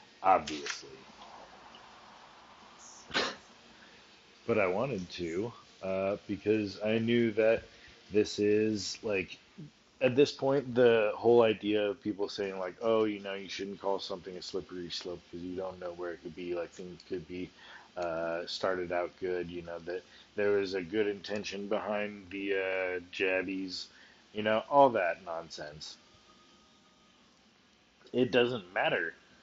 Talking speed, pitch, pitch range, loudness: 140 wpm, 100 Hz, 90-110 Hz, -32 LUFS